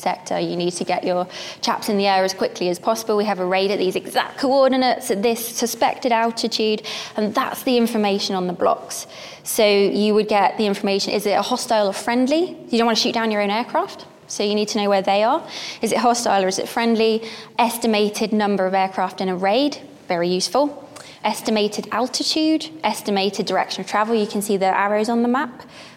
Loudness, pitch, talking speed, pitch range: -20 LUFS, 215 Hz, 215 wpm, 200-240 Hz